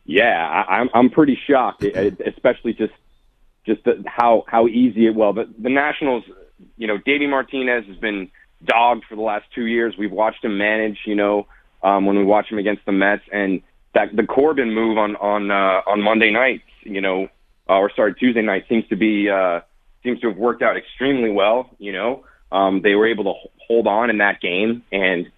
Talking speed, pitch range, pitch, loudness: 210 wpm, 100-115 Hz, 110 Hz, -18 LUFS